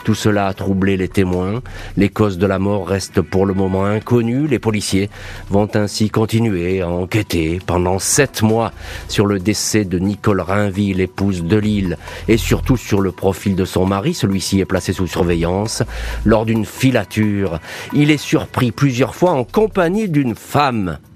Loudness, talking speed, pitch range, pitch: -17 LUFS, 170 wpm, 95-110 Hz, 100 Hz